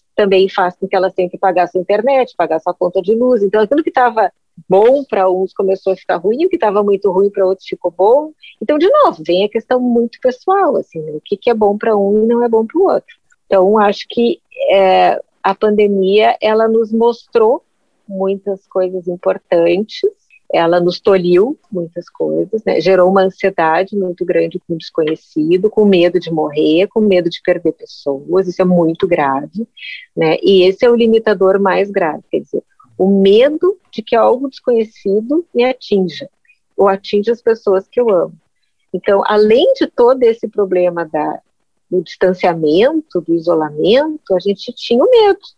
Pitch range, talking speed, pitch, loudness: 185-235 Hz, 185 wpm, 200 Hz, -13 LUFS